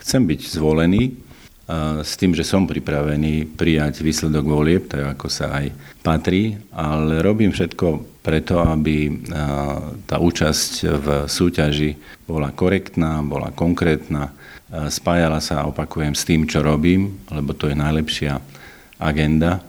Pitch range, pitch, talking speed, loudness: 75-85 Hz, 80 Hz, 125 wpm, -20 LUFS